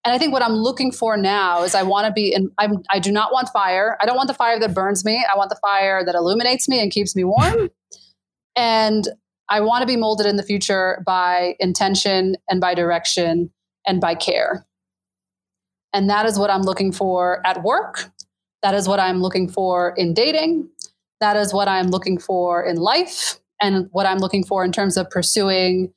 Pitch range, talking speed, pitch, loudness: 180-215 Hz, 210 wpm, 195 Hz, -19 LUFS